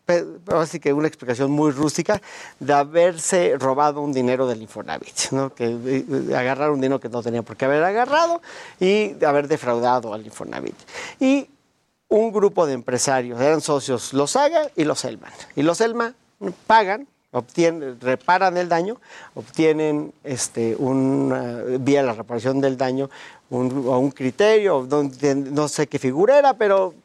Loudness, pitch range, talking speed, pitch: -21 LUFS, 130-180 Hz, 155 wpm, 145 Hz